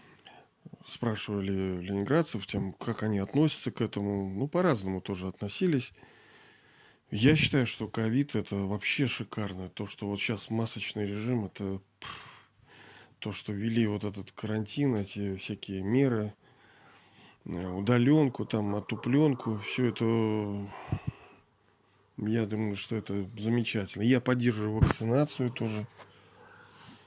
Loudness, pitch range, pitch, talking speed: -30 LUFS, 100-120 Hz, 110 Hz, 110 wpm